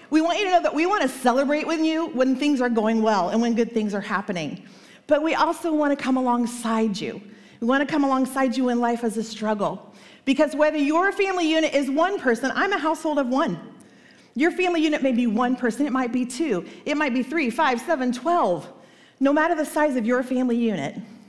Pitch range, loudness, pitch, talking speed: 235-315 Hz, -22 LUFS, 265 Hz, 230 wpm